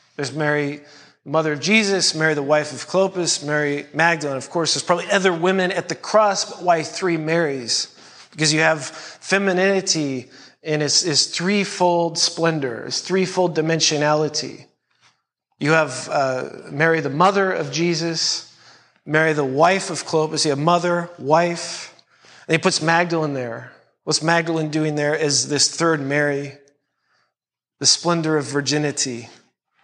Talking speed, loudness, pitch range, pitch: 145 wpm, -19 LUFS, 145-175 Hz, 160 Hz